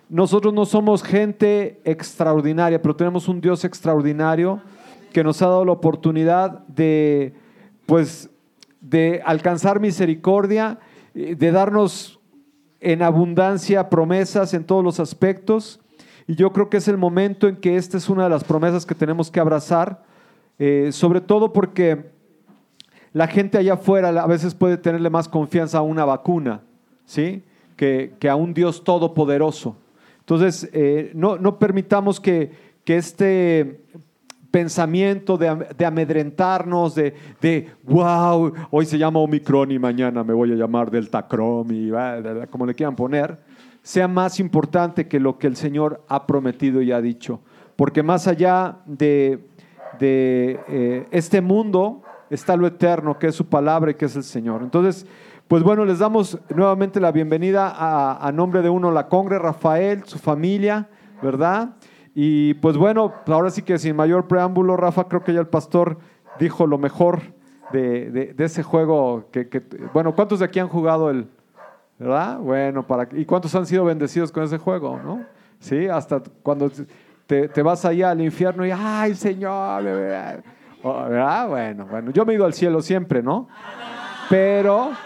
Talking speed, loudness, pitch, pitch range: 160 wpm, -19 LUFS, 170 Hz, 150-190 Hz